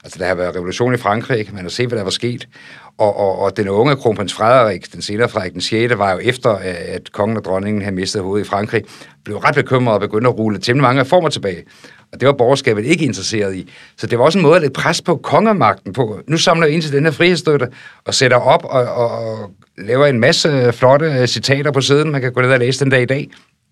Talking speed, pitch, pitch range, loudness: 250 wpm, 120 Hz, 100-140 Hz, -15 LUFS